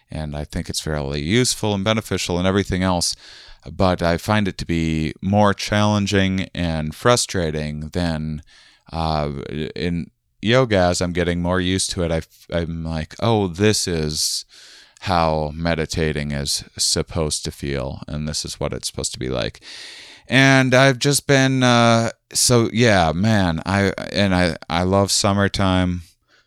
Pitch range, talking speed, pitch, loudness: 80-105 Hz, 150 wpm, 90 Hz, -19 LUFS